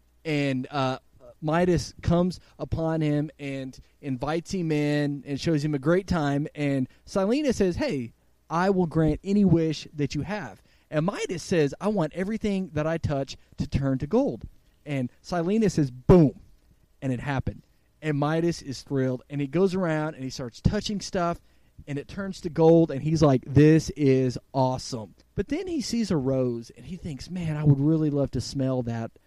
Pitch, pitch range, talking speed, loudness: 150 Hz, 135-170 Hz, 180 wpm, -26 LUFS